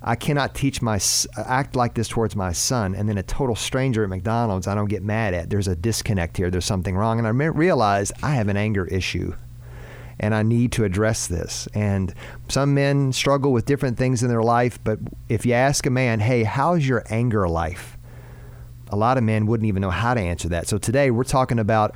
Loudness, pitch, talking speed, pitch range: -22 LUFS, 115 Hz, 220 wpm, 100-125 Hz